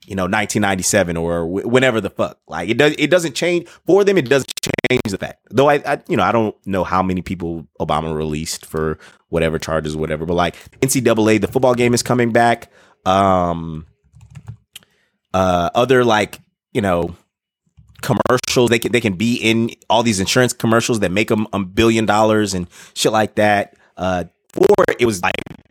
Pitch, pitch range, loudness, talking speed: 110 Hz, 90-125 Hz, -17 LUFS, 185 wpm